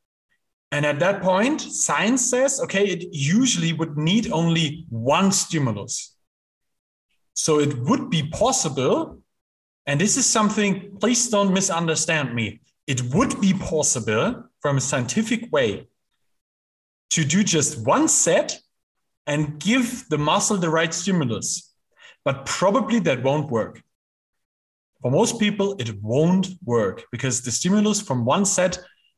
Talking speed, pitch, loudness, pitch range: 130 wpm, 165 Hz, -21 LUFS, 140-205 Hz